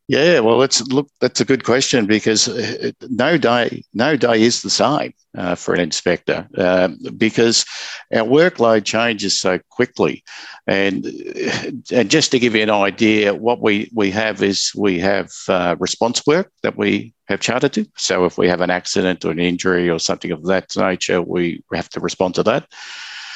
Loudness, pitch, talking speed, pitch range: -17 LUFS, 110 Hz, 180 wpm, 95-120 Hz